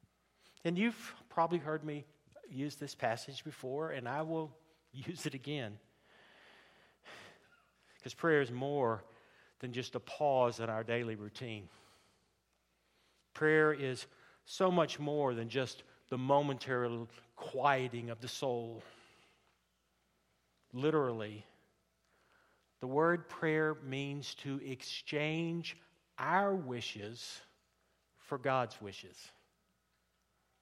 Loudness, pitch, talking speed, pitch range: -37 LUFS, 130 Hz, 100 wpm, 115-150 Hz